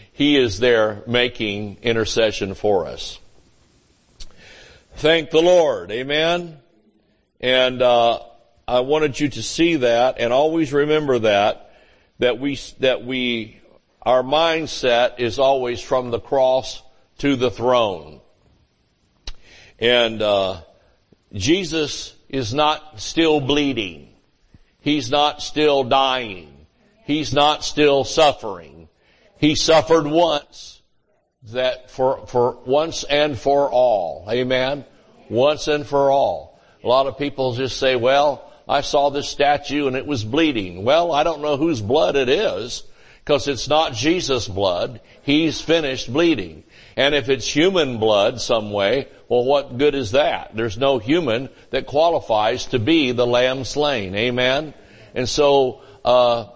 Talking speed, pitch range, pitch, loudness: 130 wpm, 120-150 Hz, 135 Hz, -19 LUFS